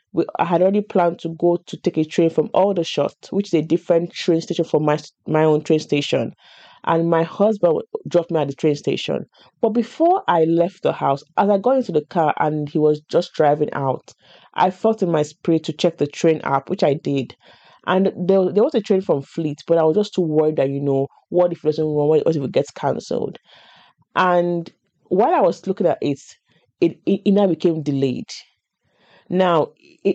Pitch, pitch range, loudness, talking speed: 165 Hz, 155-185 Hz, -19 LUFS, 210 wpm